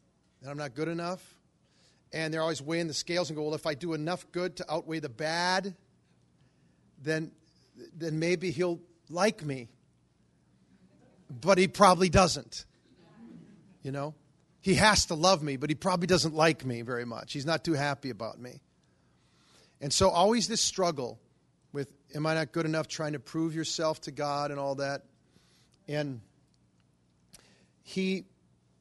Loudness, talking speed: -30 LUFS, 160 wpm